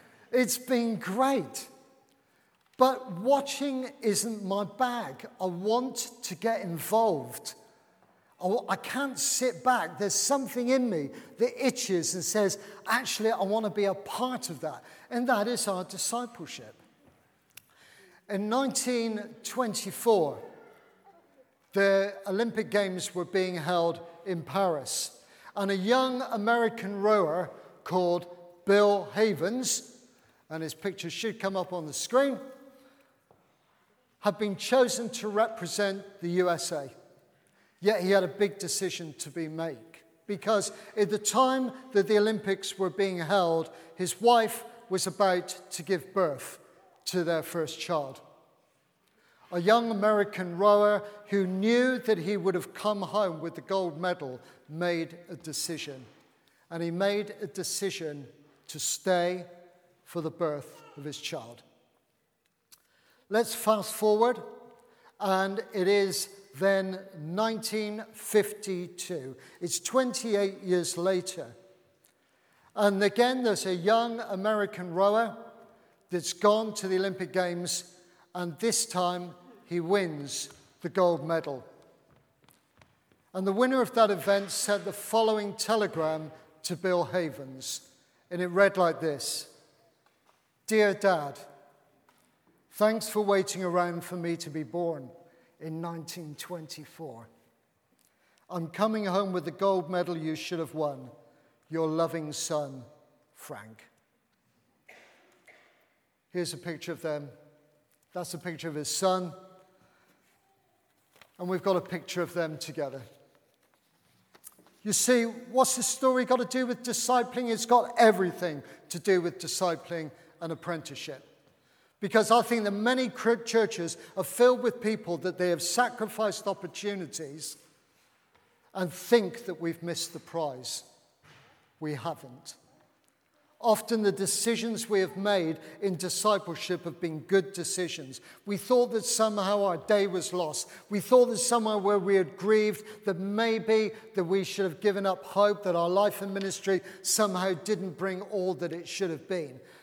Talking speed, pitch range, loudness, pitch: 130 wpm, 170-220 Hz, -29 LUFS, 195 Hz